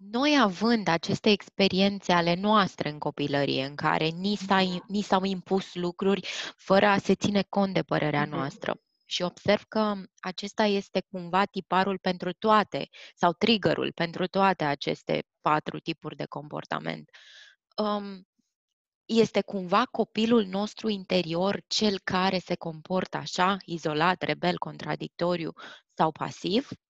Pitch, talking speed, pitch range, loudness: 190 Hz, 125 wpm, 170-205 Hz, -27 LUFS